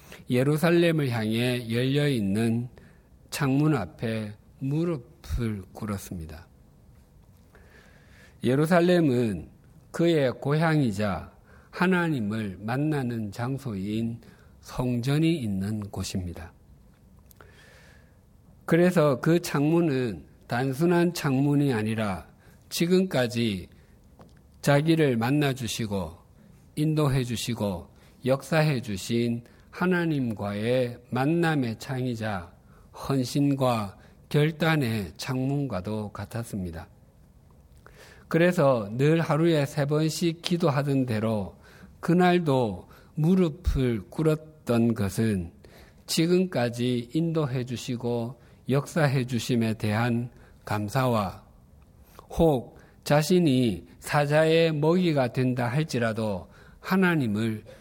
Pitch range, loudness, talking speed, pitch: 105-150 Hz, -26 LUFS, 195 characters per minute, 125 Hz